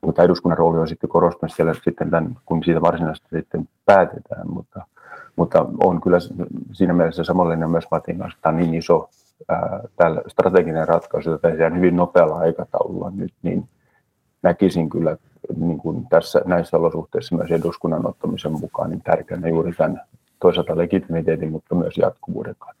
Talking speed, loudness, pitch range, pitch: 160 wpm, -20 LUFS, 80-85 Hz, 85 Hz